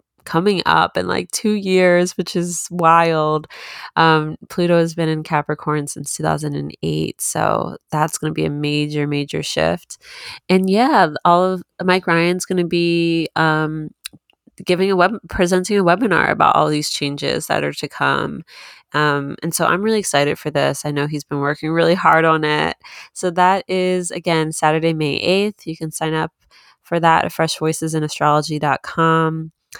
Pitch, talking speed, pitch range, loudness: 160 Hz, 170 wpm, 150-180 Hz, -18 LUFS